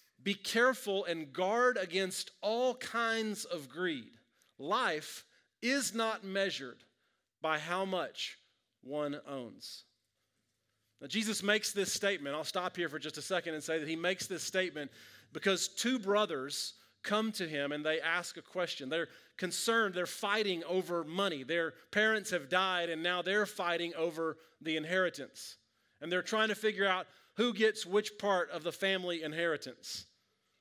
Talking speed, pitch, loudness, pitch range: 155 wpm, 180 Hz, -34 LUFS, 160-210 Hz